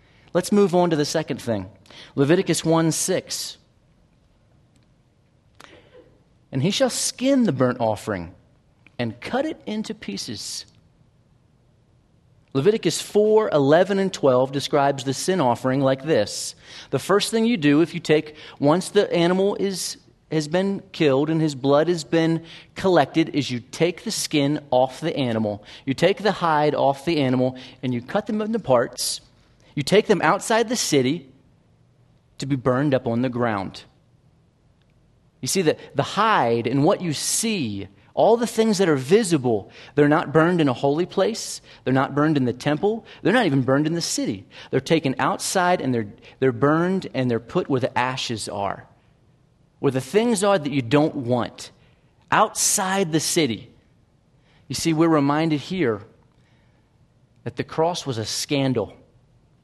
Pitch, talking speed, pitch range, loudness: 145 Hz, 160 wpm, 130-175 Hz, -22 LUFS